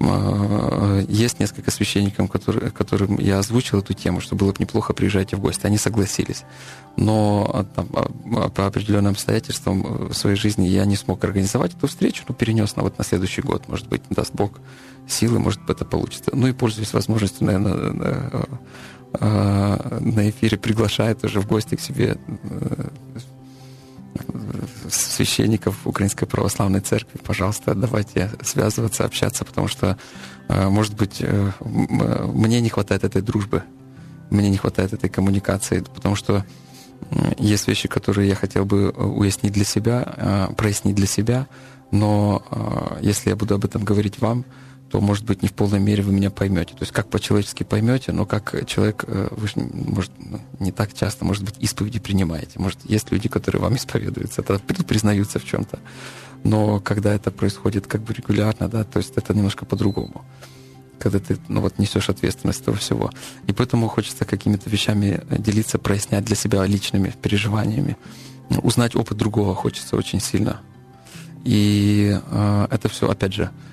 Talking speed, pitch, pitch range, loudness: 150 wpm, 105 Hz, 100-120 Hz, -21 LUFS